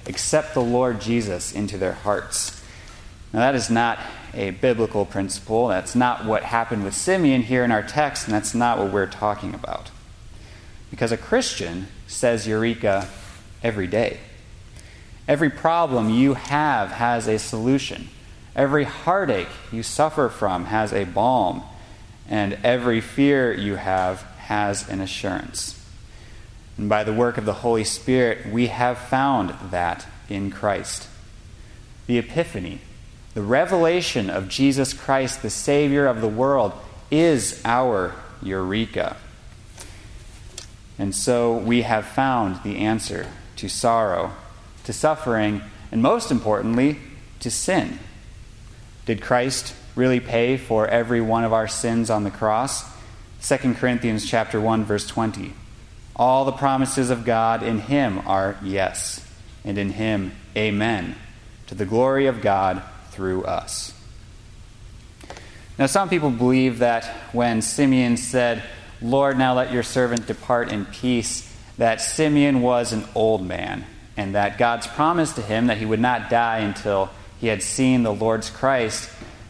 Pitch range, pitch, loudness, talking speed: 100-125 Hz, 110 Hz, -22 LUFS, 140 wpm